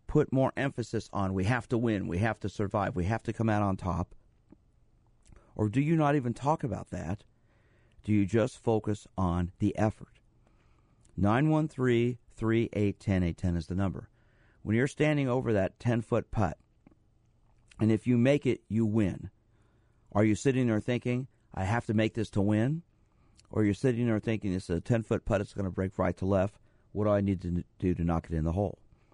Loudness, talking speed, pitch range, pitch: -30 LUFS, 210 wpm, 100-120 Hz, 110 Hz